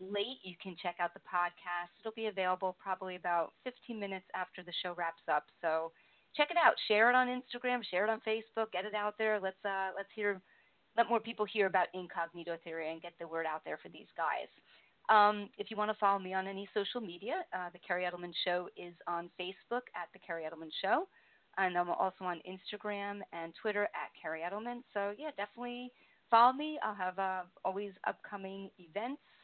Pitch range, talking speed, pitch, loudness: 175-215 Hz, 205 wpm, 195 Hz, -36 LUFS